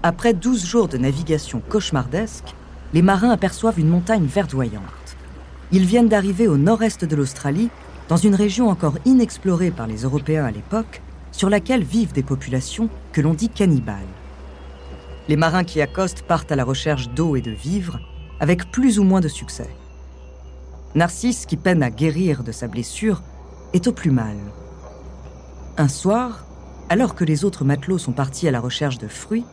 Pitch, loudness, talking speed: 155 Hz, -20 LUFS, 165 wpm